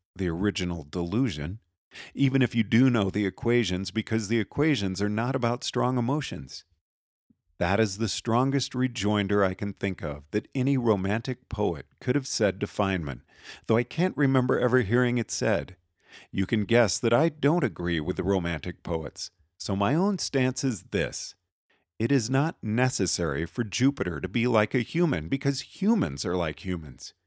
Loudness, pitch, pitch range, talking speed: -27 LUFS, 110 Hz, 95-130 Hz, 170 wpm